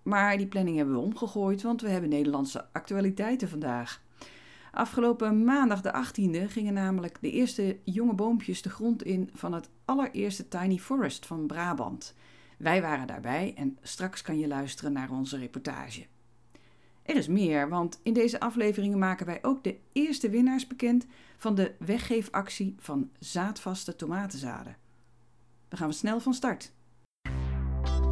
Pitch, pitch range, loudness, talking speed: 190 Hz, 140-220 Hz, -30 LUFS, 145 wpm